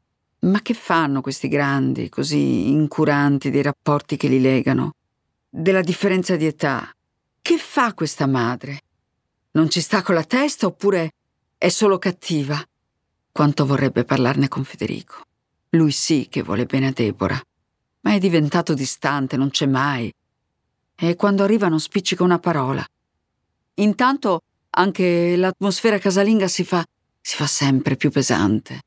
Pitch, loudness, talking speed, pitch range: 150 Hz, -20 LUFS, 140 wpm, 135-185 Hz